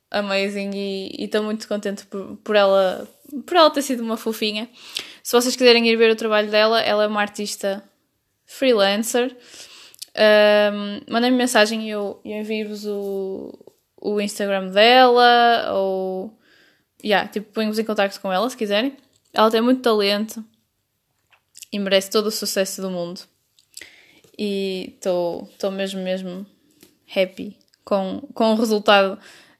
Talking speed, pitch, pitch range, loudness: 140 wpm, 210 Hz, 200-230 Hz, -19 LUFS